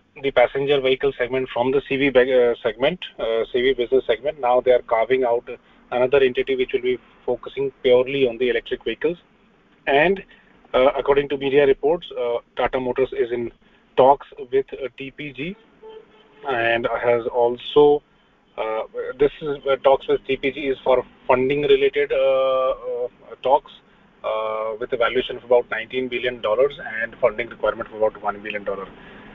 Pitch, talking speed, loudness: 180 Hz, 160 wpm, -21 LUFS